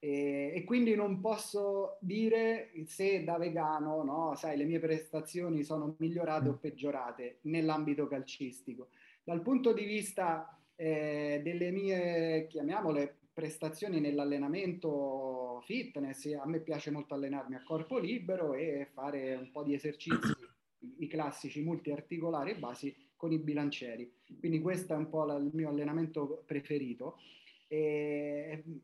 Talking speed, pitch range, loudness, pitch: 130 wpm, 145-165 Hz, -36 LUFS, 155 Hz